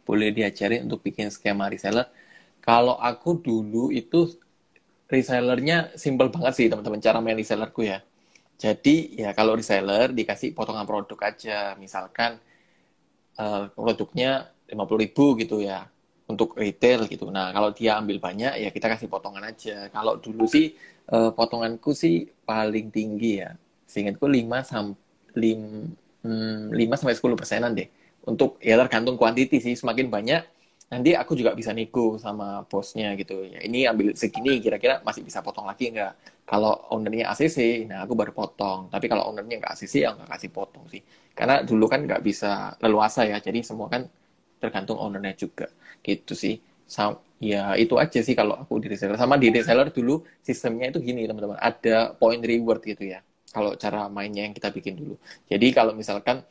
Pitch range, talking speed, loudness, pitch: 100-120 Hz, 160 wpm, -24 LUFS, 110 Hz